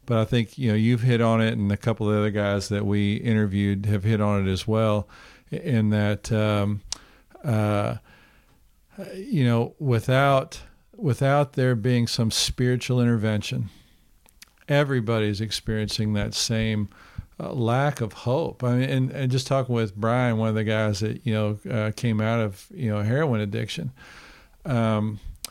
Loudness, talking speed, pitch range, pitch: -24 LUFS, 165 wpm, 105-125 Hz, 110 Hz